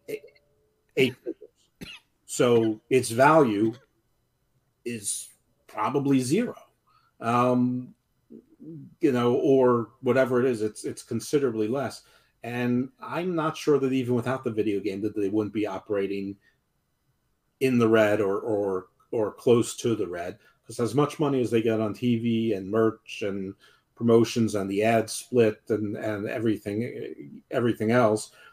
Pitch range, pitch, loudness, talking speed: 110-130 Hz, 115 Hz, -25 LUFS, 135 wpm